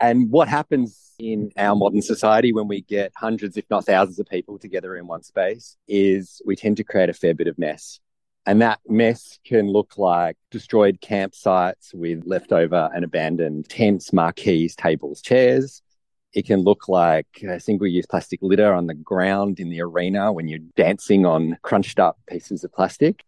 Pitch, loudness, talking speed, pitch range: 100 Hz, -20 LUFS, 180 wpm, 90-110 Hz